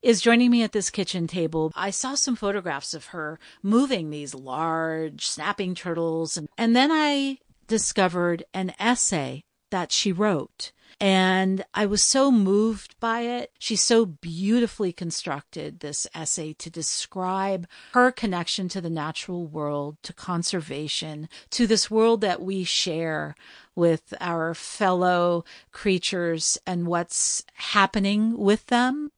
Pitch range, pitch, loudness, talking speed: 165-220 Hz, 185 Hz, -24 LUFS, 135 wpm